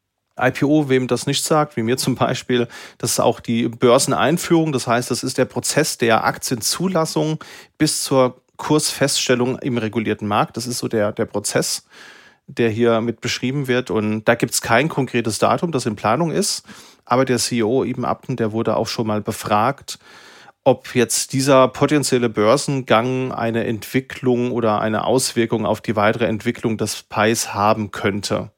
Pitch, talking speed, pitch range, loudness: 120 Hz, 165 wpm, 110-130 Hz, -19 LUFS